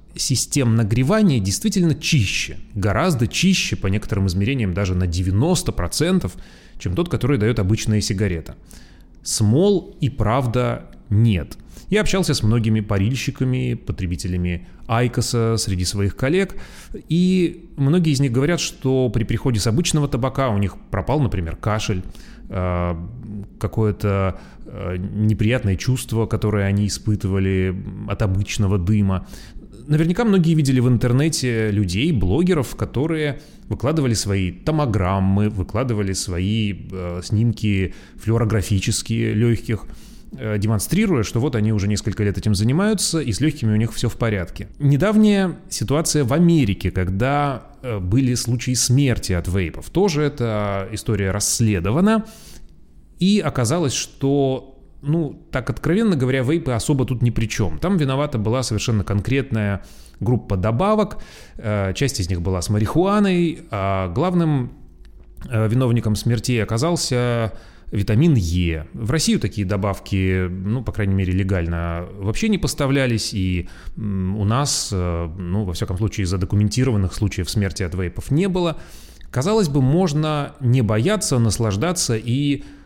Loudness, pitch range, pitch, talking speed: -20 LUFS, 100-140 Hz, 115 Hz, 125 wpm